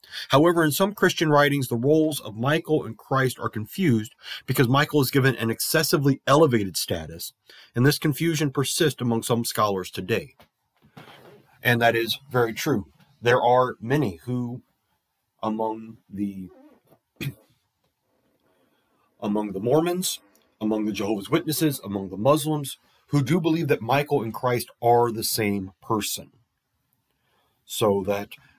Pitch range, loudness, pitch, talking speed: 110-150 Hz, -23 LUFS, 125 Hz, 130 wpm